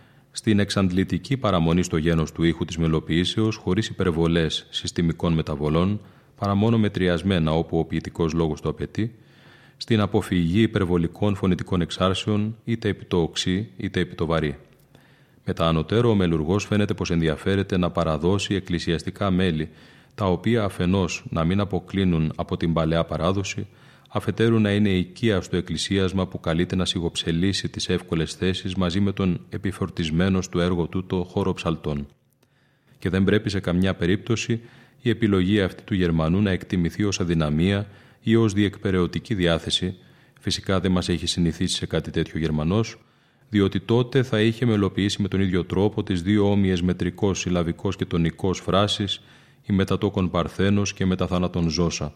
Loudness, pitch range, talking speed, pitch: -23 LUFS, 85-105 Hz, 150 wpm, 95 Hz